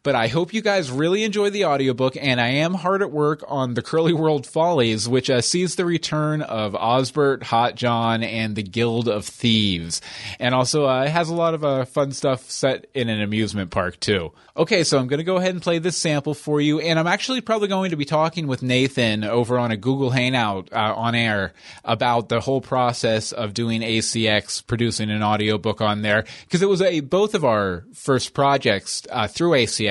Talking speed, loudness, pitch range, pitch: 215 wpm, -21 LUFS, 115-155 Hz, 130 Hz